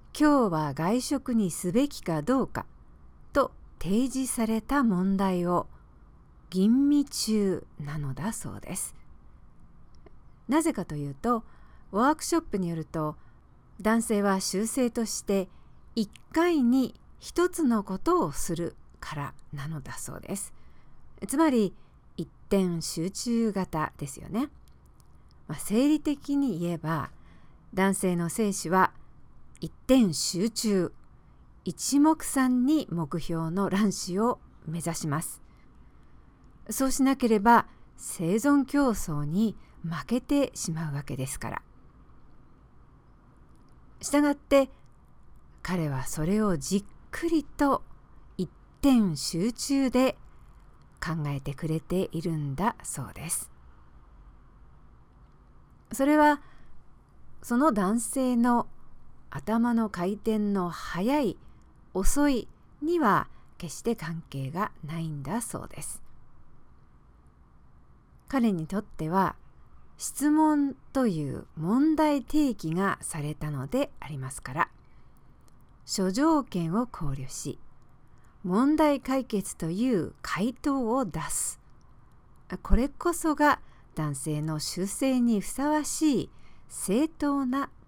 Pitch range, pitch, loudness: 160-265 Hz, 205 Hz, -28 LUFS